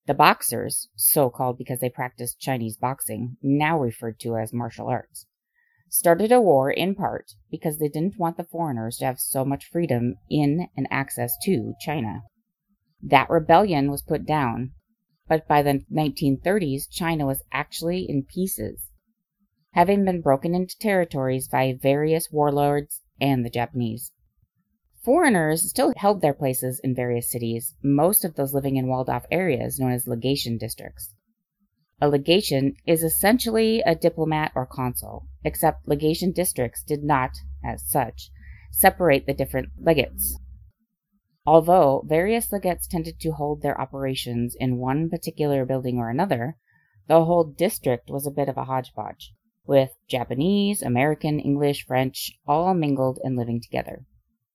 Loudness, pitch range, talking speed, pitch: -23 LUFS, 125-170 Hz, 145 wpm, 140 Hz